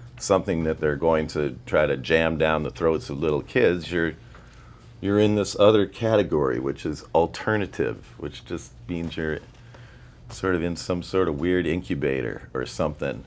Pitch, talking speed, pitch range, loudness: 90 Hz, 165 wpm, 80-105 Hz, -24 LUFS